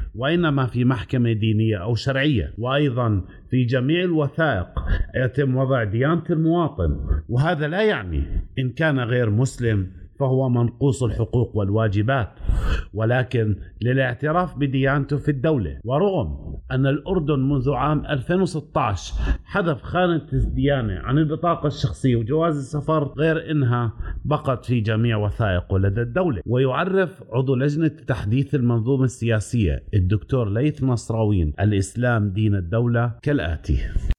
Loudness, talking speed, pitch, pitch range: -22 LUFS, 115 wpm, 125 Hz, 105-145 Hz